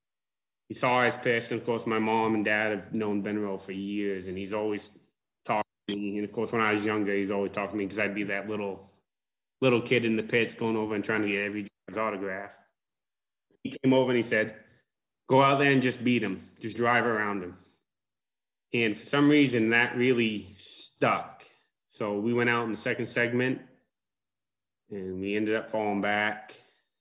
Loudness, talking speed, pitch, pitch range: -28 LUFS, 200 wpm, 110 Hz, 100-120 Hz